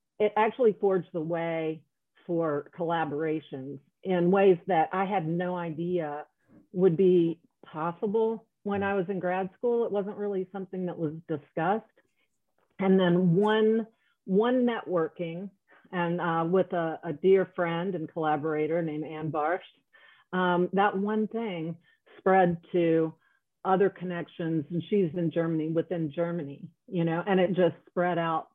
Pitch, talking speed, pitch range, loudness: 175 Hz, 145 wpm, 165-195 Hz, -28 LUFS